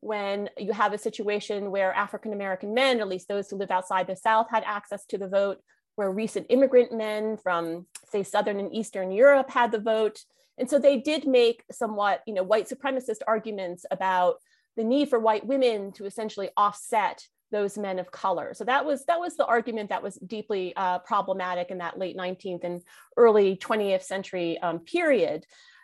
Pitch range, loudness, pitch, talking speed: 190-230 Hz, -26 LUFS, 210 Hz, 185 wpm